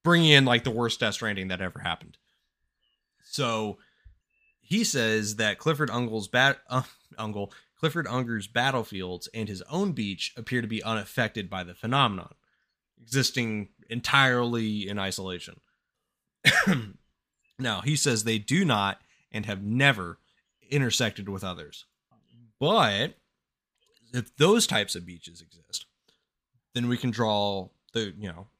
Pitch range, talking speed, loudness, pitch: 100-130 Hz, 130 wpm, -26 LUFS, 115 Hz